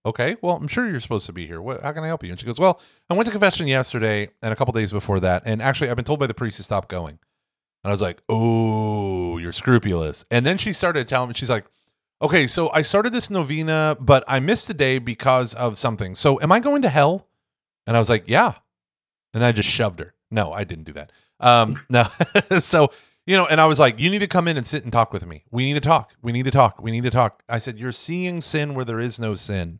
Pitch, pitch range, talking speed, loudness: 125 Hz, 105-155 Hz, 270 wpm, -20 LUFS